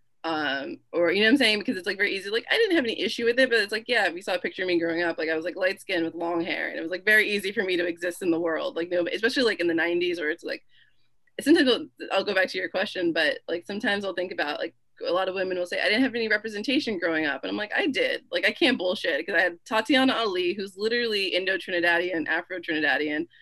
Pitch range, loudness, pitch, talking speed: 175-235 Hz, -25 LUFS, 190 Hz, 280 wpm